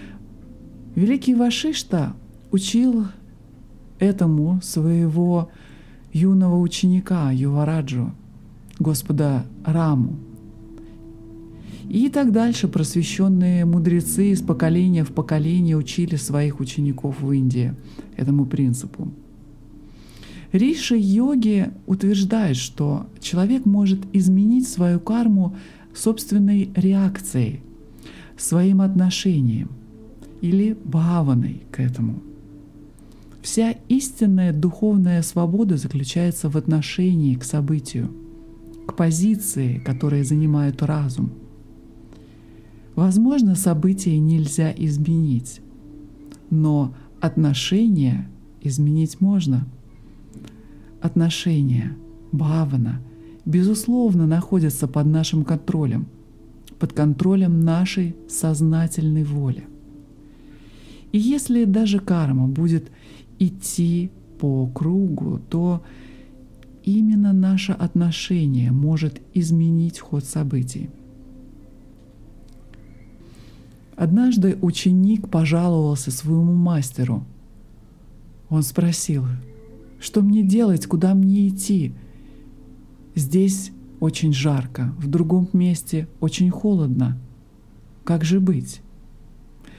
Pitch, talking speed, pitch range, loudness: 160 Hz, 80 wpm, 130-185 Hz, -20 LUFS